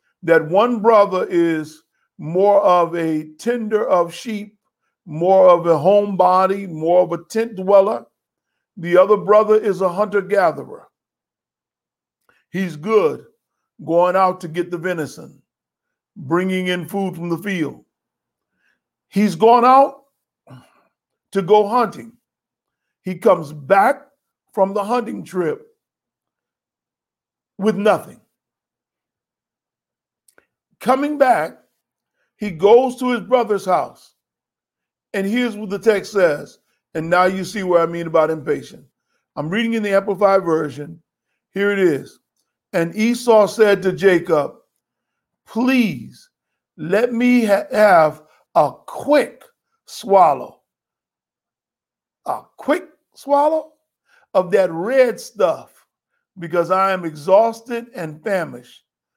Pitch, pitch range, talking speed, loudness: 195 Hz, 175-225 Hz, 115 wpm, -17 LUFS